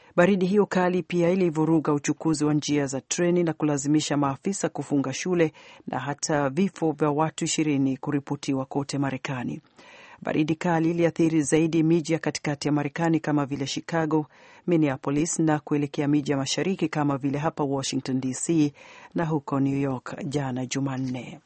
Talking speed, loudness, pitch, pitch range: 150 wpm, -25 LUFS, 150 Hz, 140-165 Hz